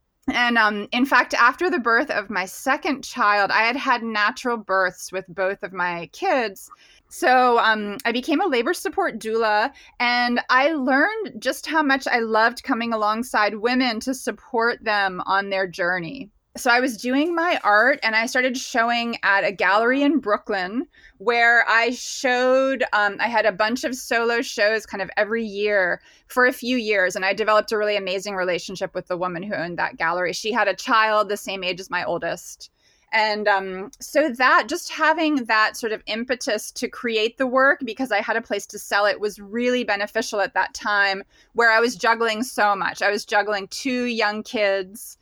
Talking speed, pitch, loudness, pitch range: 190 wpm, 225 Hz, -21 LUFS, 205-255 Hz